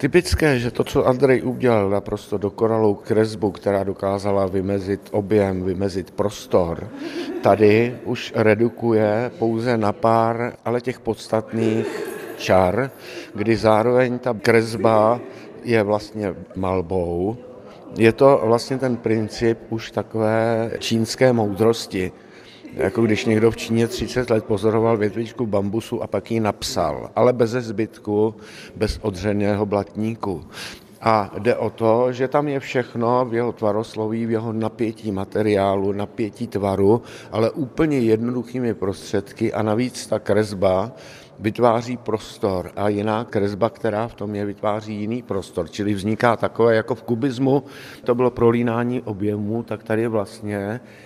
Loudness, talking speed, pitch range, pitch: -21 LUFS, 130 wpm, 105-120 Hz, 110 Hz